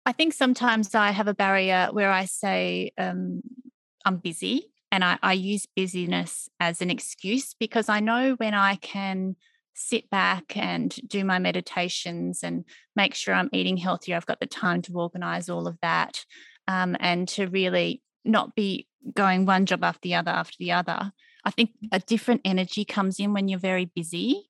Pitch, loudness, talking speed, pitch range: 190 Hz, -26 LUFS, 180 wpm, 180-220 Hz